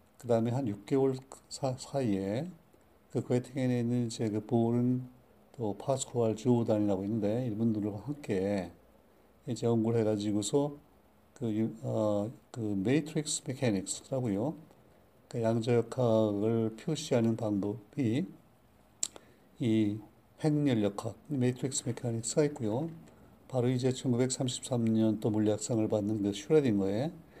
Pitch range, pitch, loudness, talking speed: 110-130 Hz, 115 Hz, -32 LUFS, 255 characters per minute